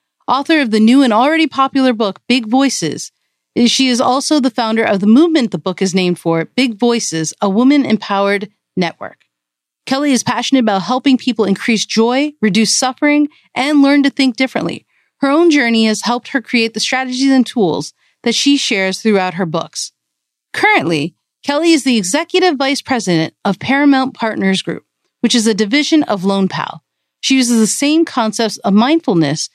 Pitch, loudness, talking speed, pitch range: 240 Hz, -13 LUFS, 175 wpm, 205-275 Hz